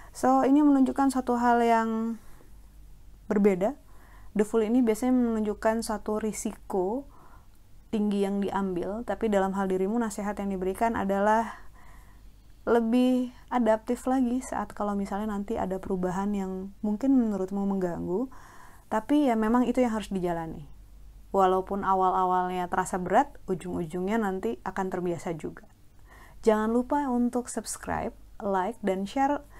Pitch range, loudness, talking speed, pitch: 190-235 Hz, -27 LUFS, 125 wpm, 210 Hz